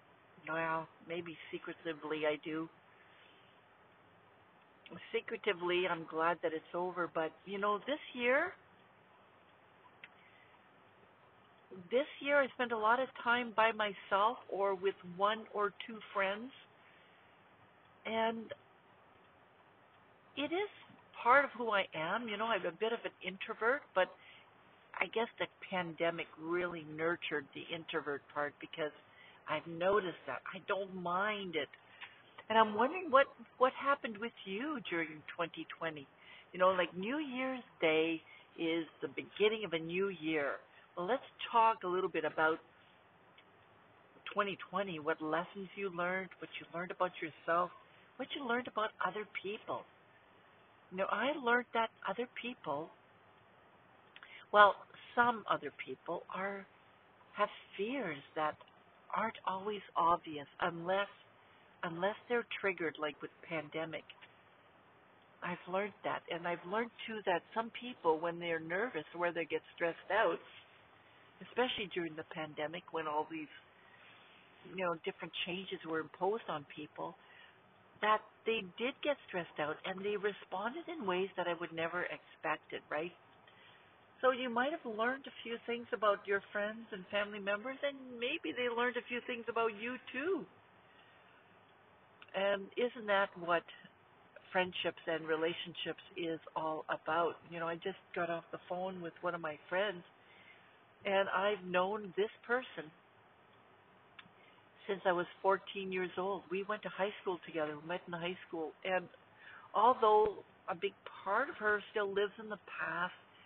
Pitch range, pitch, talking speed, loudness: 170-225 Hz, 190 Hz, 145 wpm, -37 LUFS